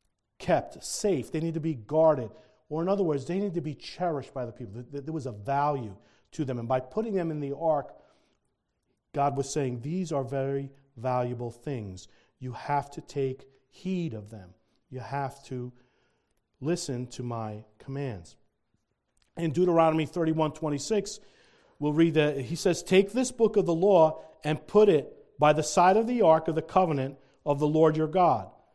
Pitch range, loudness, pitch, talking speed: 130-165 Hz, -28 LUFS, 150 Hz, 180 wpm